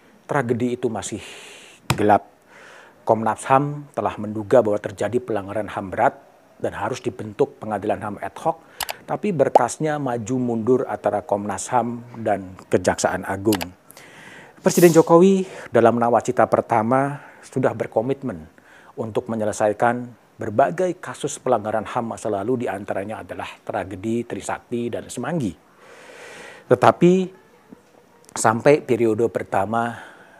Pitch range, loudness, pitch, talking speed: 105-135 Hz, -21 LUFS, 115 Hz, 110 wpm